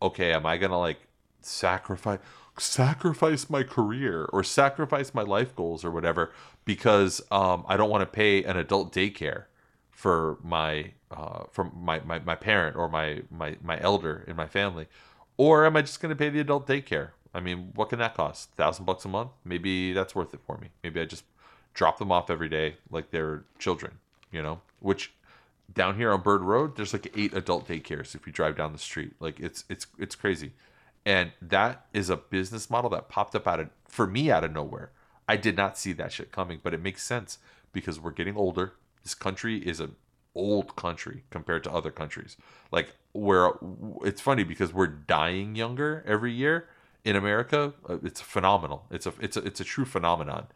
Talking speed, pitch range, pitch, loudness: 195 wpm, 85-120 Hz, 100 Hz, -28 LUFS